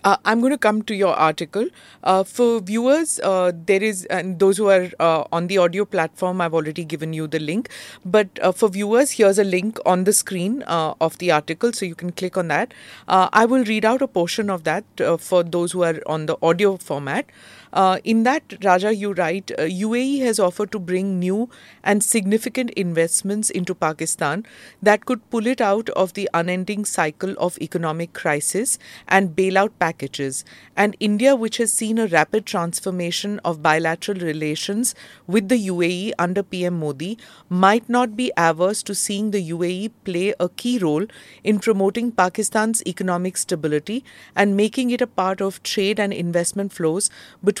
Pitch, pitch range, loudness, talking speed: 195 Hz, 175-215 Hz, -20 LUFS, 185 wpm